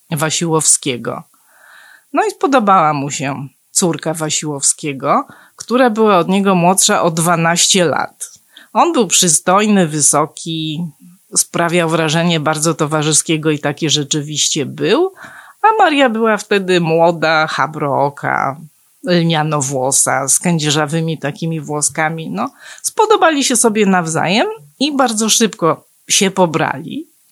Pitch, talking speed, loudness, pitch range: 165 Hz, 110 wpm, -14 LUFS, 155-200 Hz